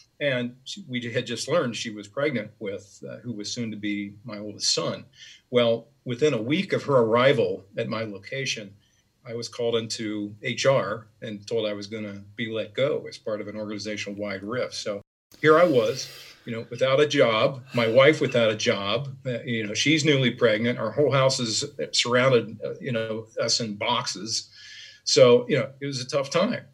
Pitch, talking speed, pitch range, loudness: 115 Hz, 195 wpm, 105-135 Hz, -24 LUFS